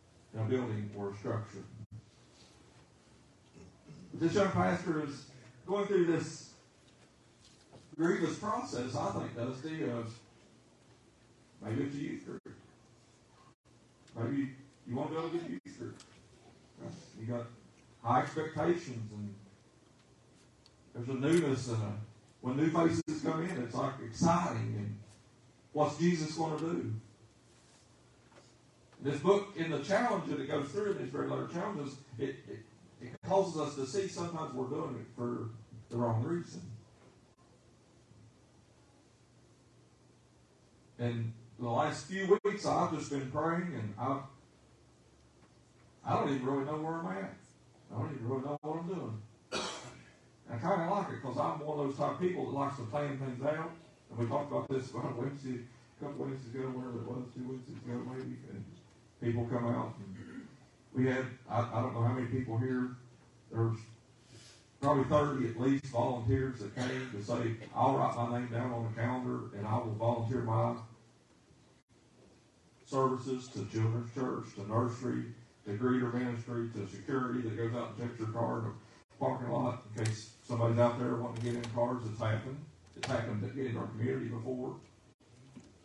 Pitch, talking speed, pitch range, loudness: 125 Hz, 160 wpm, 115-140 Hz, -36 LUFS